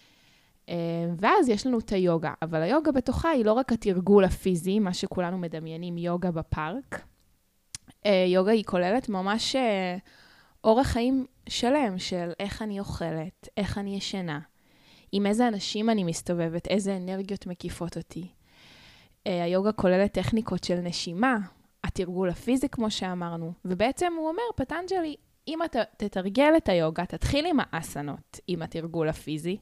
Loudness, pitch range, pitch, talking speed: -27 LUFS, 175-225 Hz, 190 Hz, 130 wpm